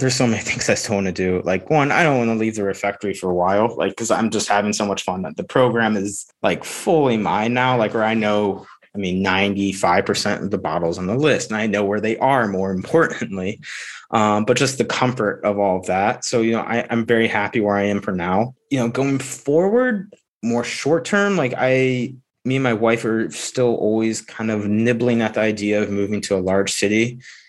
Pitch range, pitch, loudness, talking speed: 100-125 Hz, 110 Hz, -19 LUFS, 235 wpm